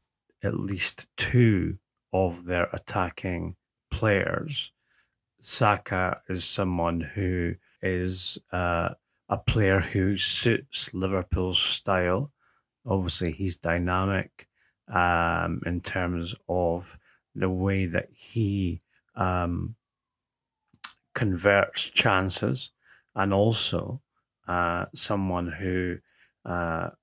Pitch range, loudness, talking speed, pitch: 85-100 Hz, -25 LUFS, 85 wpm, 95 Hz